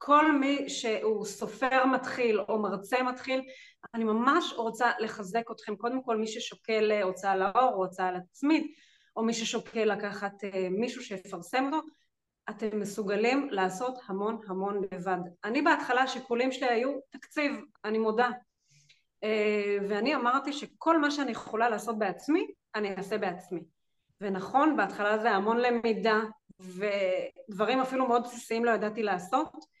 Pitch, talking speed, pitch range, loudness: 225 Hz, 135 wpm, 205-260 Hz, -30 LUFS